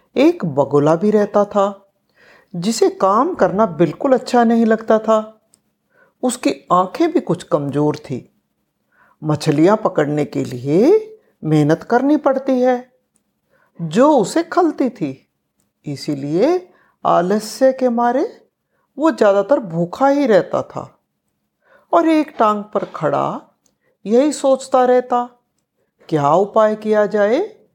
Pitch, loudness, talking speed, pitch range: 220 Hz, -16 LUFS, 115 wpm, 175-270 Hz